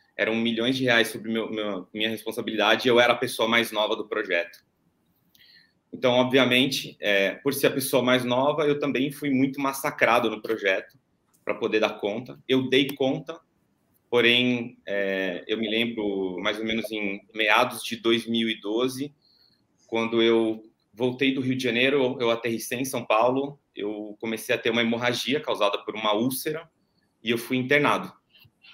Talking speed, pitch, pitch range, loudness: 165 wpm, 120 Hz, 110-130 Hz, -24 LUFS